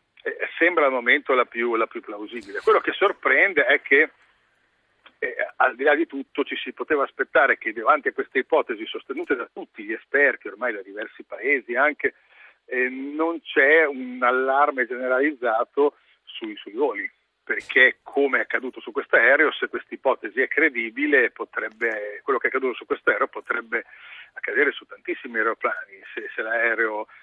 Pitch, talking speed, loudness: 385 Hz, 170 wpm, -22 LUFS